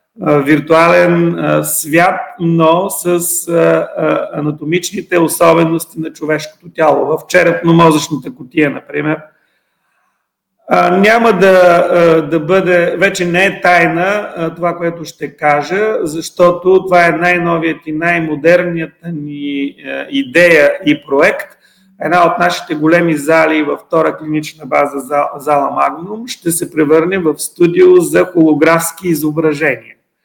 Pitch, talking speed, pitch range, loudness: 165 Hz, 105 wpm, 155-175 Hz, -11 LUFS